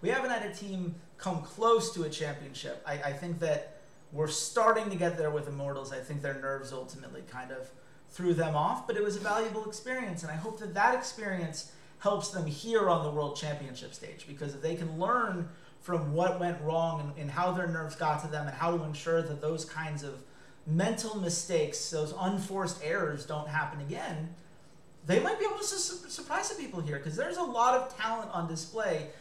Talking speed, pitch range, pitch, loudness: 210 wpm, 150-200 Hz, 165 Hz, -33 LUFS